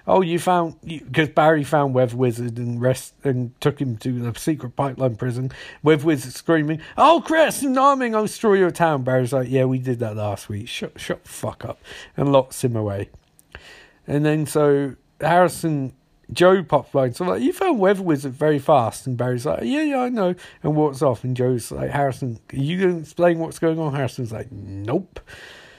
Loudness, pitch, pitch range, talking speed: -21 LUFS, 145 Hz, 125-170 Hz, 200 wpm